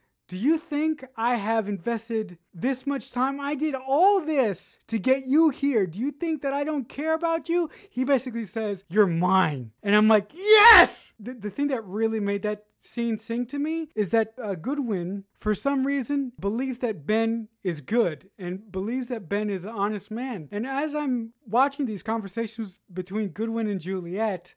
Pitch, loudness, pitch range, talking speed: 230 Hz, -25 LUFS, 205-275 Hz, 185 wpm